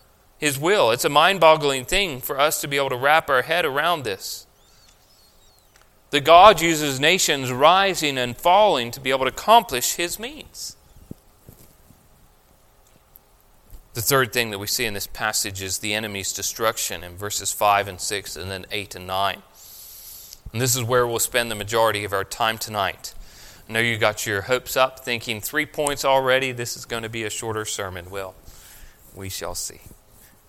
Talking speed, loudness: 175 wpm, -20 LUFS